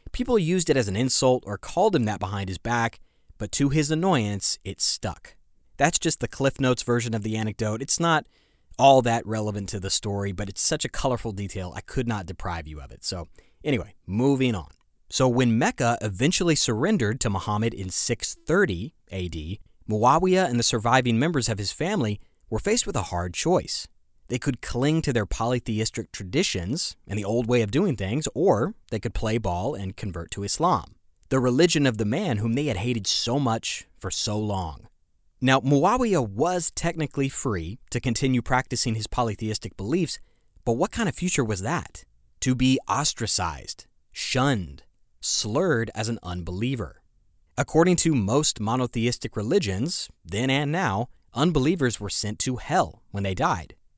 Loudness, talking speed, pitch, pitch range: -24 LUFS, 175 wpm, 115 Hz, 100-135 Hz